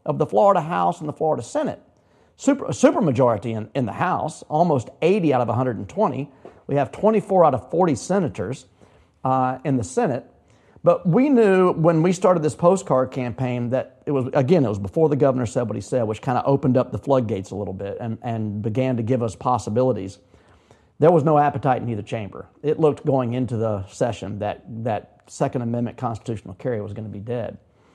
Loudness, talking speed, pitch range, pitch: -21 LUFS, 200 wpm, 110-145 Hz, 125 Hz